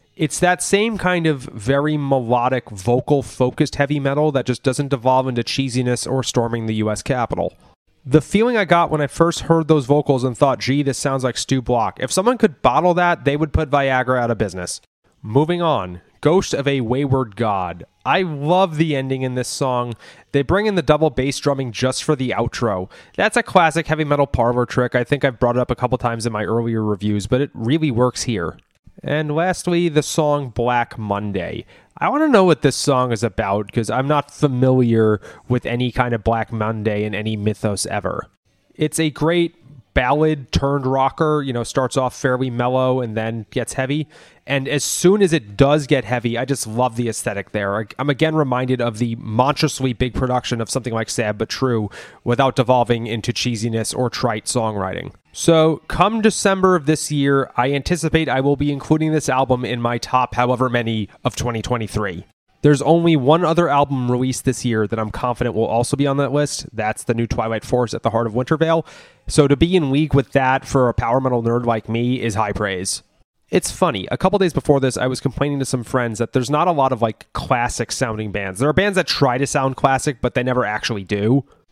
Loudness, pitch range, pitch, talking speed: -19 LUFS, 120-150 Hz, 130 Hz, 210 wpm